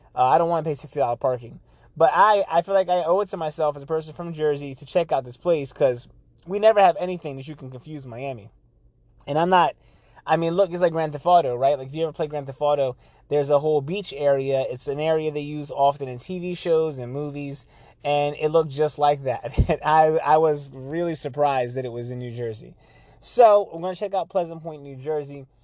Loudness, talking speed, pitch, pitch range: -23 LUFS, 240 wpm, 150 Hz, 135-165 Hz